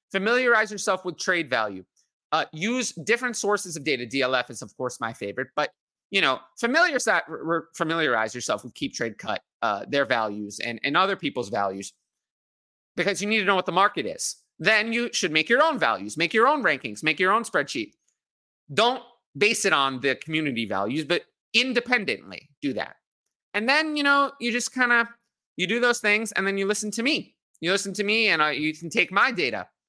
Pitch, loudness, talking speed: 195 Hz, -24 LUFS, 200 wpm